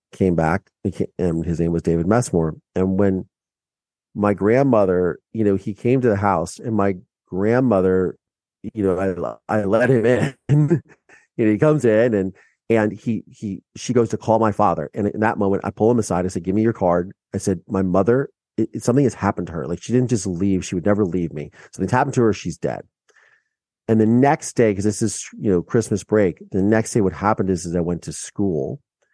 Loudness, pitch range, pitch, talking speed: -20 LUFS, 95-110 Hz, 100 Hz, 220 wpm